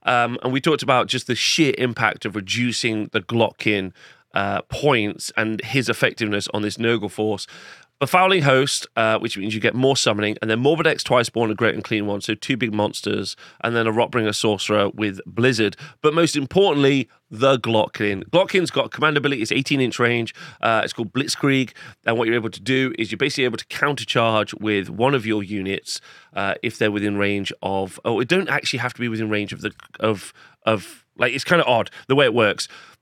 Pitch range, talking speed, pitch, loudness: 105-130 Hz, 215 wpm, 115 Hz, -21 LUFS